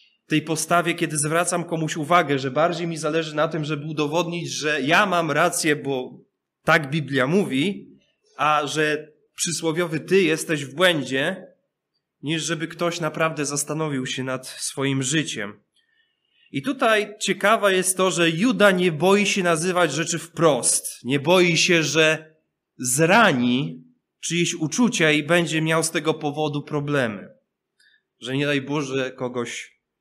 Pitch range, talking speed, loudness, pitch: 150-175 Hz, 140 wpm, -21 LUFS, 160 Hz